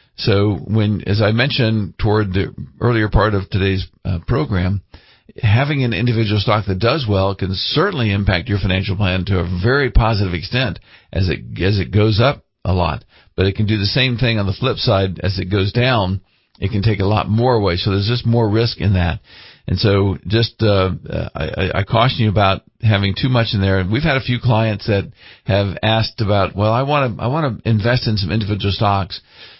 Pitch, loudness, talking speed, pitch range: 105 Hz, -17 LUFS, 210 wpm, 95-115 Hz